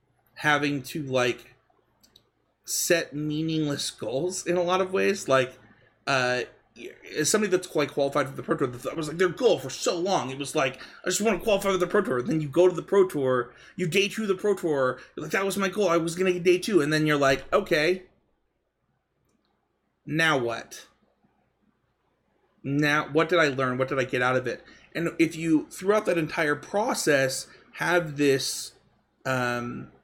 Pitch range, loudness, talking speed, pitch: 135-180 Hz, -25 LUFS, 190 wpm, 155 Hz